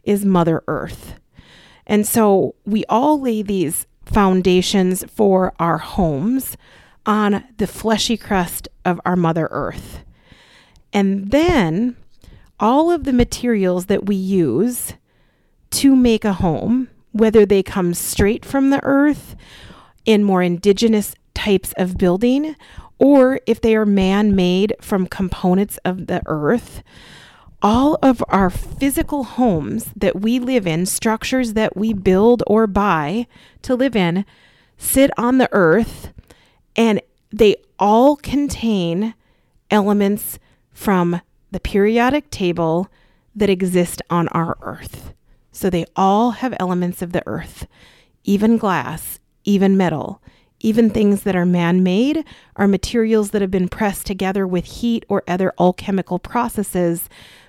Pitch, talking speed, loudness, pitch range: 200 Hz, 130 wpm, -17 LUFS, 180-230 Hz